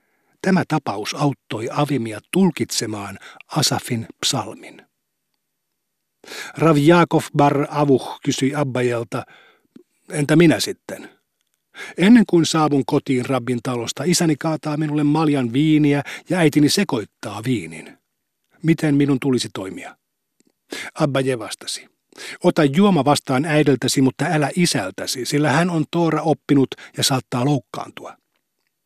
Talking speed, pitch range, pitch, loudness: 110 wpm, 130-155 Hz, 145 Hz, -19 LUFS